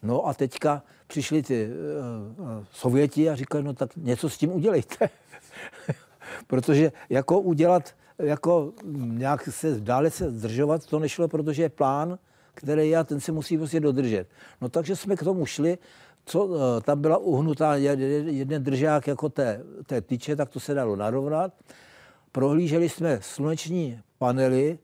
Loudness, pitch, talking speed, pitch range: -26 LUFS, 150 Hz, 150 wpm, 135-160 Hz